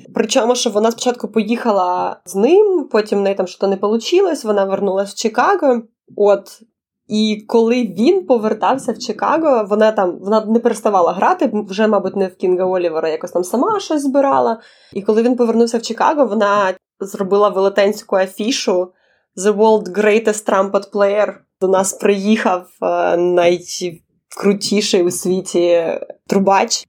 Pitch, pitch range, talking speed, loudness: 210 Hz, 195-235 Hz, 145 wpm, -16 LUFS